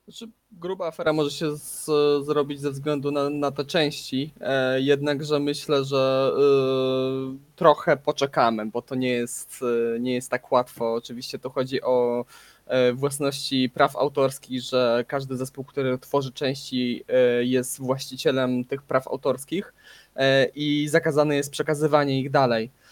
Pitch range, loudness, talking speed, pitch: 125-145 Hz, -24 LUFS, 150 wpm, 135 Hz